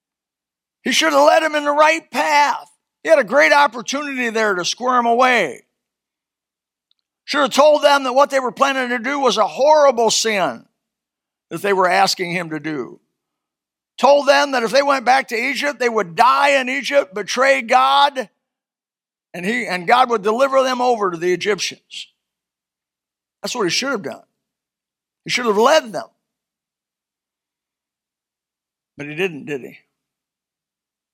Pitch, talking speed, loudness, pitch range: 255 Hz, 160 wpm, -16 LUFS, 220-280 Hz